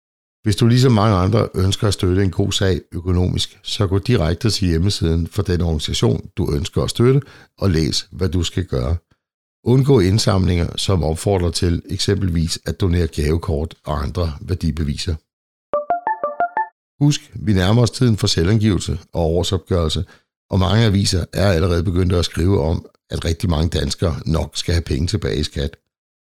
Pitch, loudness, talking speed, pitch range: 95 Hz, -19 LUFS, 160 wpm, 85-105 Hz